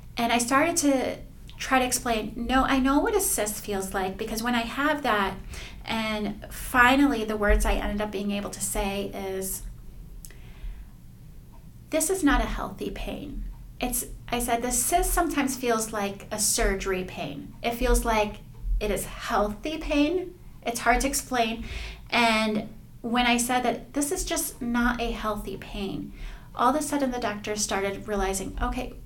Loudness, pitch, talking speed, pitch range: -26 LUFS, 235 Hz, 165 wpm, 210-265 Hz